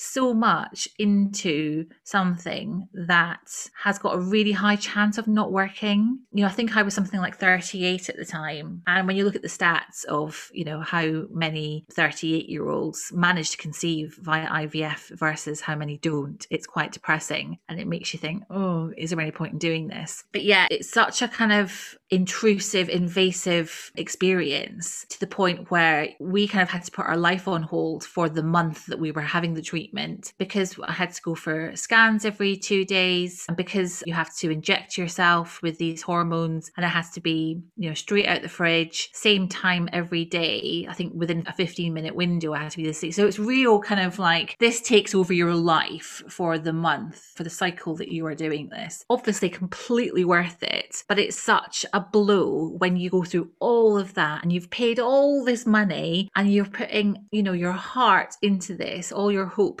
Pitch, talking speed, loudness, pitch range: 180 Hz, 205 wpm, -24 LUFS, 165-200 Hz